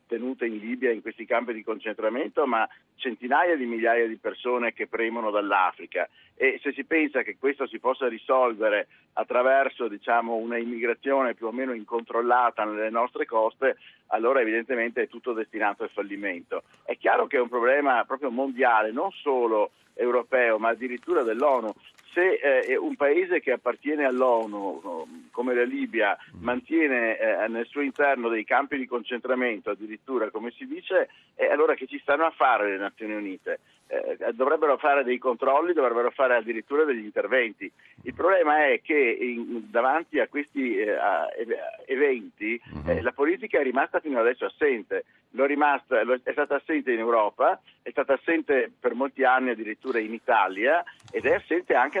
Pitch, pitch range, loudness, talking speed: 130 Hz, 115-165 Hz, -25 LUFS, 160 wpm